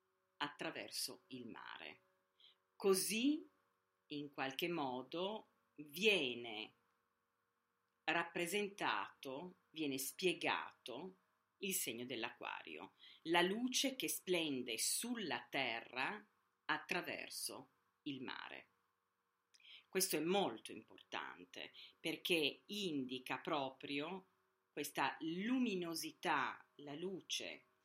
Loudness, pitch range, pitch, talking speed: -42 LUFS, 145-205 Hz, 175 Hz, 75 wpm